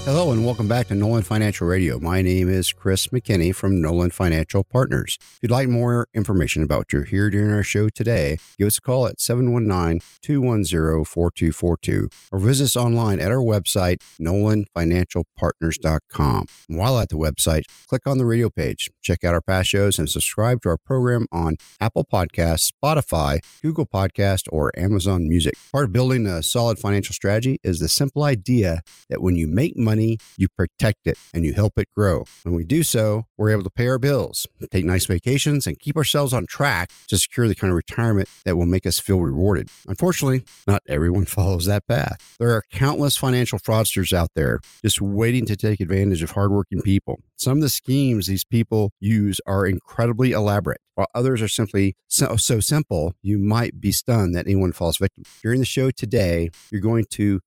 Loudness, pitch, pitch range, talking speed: -21 LUFS, 100 Hz, 90-120 Hz, 190 wpm